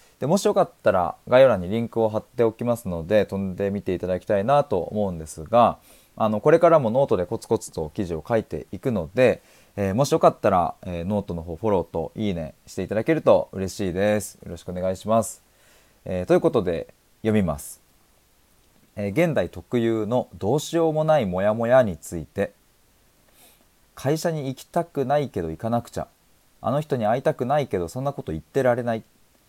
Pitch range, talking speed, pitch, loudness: 95-135 Hz, 395 characters per minute, 110 Hz, -23 LUFS